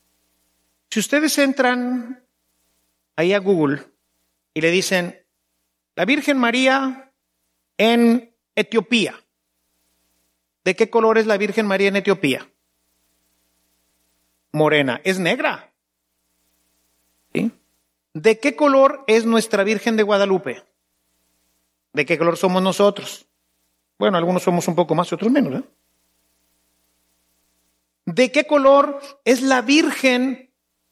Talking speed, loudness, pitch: 105 wpm, -18 LUFS, 155 Hz